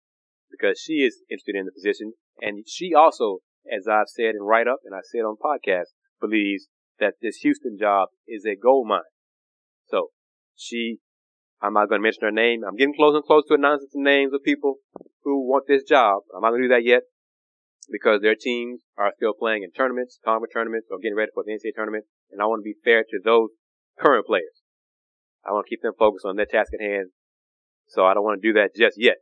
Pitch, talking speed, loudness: 135 Hz, 220 wpm, -22 LUFS